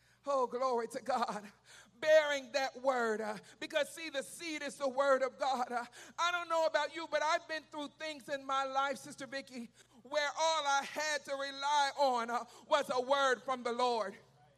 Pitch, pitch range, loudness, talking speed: 275 Hz, 250-300 Hz, -35 LUFS, 195 wpm